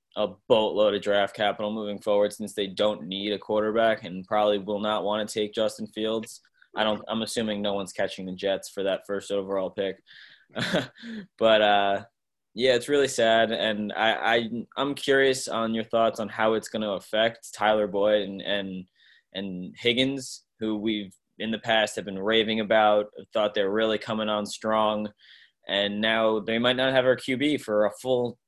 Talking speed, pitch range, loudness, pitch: 185 wpm, 105-115 Hz, -26 LUFS, 110 Hz